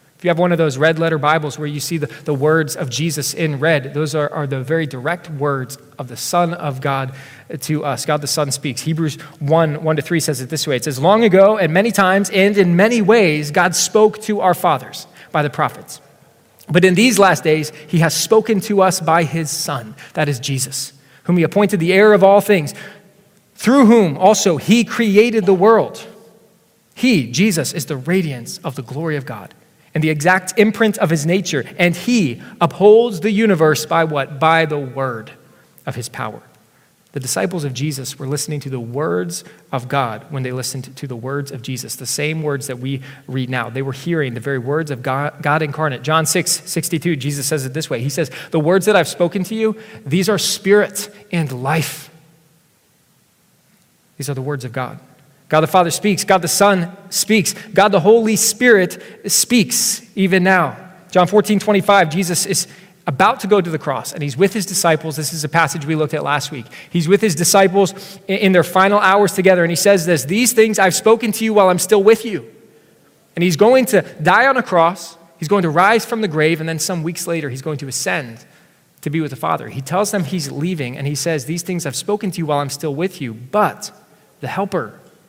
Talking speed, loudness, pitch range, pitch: 215 wpm, -16 LUFS, 145-195 Hz, 165 Hz